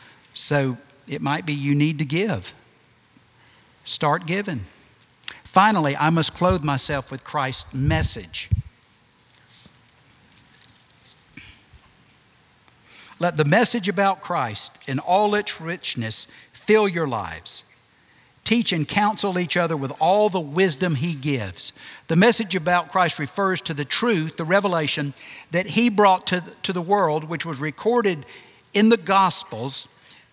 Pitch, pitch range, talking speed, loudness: 155 Hz, 130-190 Hz, 125 wpm, -22 LUFS